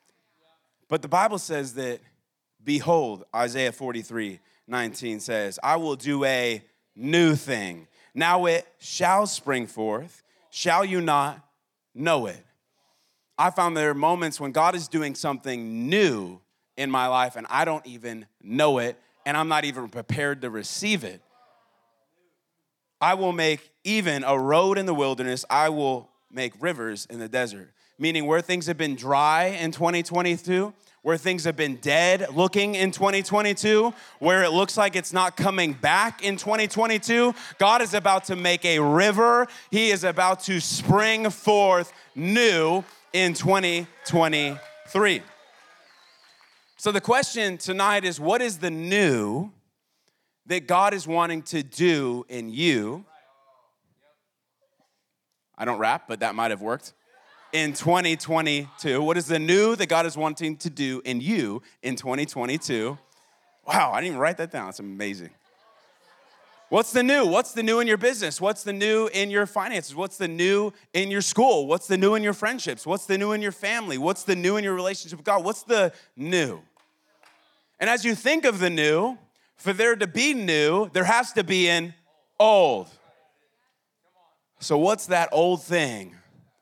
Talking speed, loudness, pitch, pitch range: 160 wpm, -23 LUFS, 170 Hz, 145-200 Hz